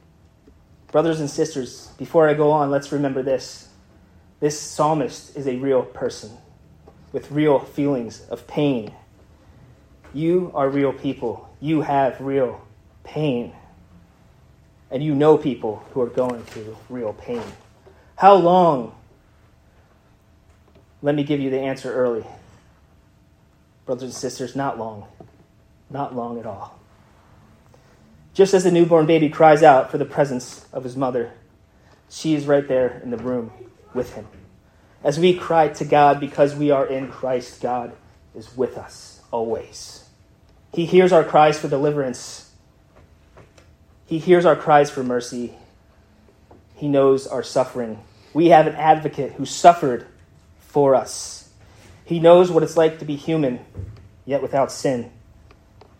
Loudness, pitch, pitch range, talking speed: -19 LUFS, 130 Hz, 105-150 Hz, 140 wpm